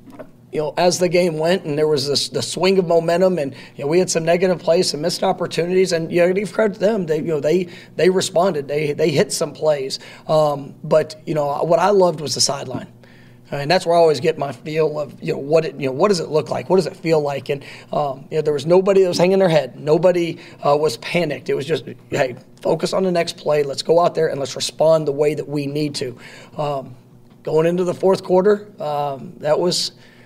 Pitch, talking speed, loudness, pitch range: 165 Hz, 260 wpm, -19 LUFS, 150-180 Hz